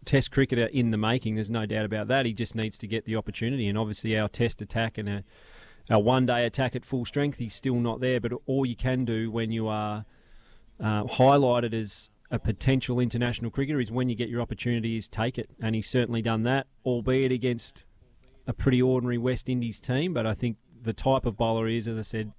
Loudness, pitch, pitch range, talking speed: -28 LUFS, 115 Hz, 110-125 Hz, 220 wpm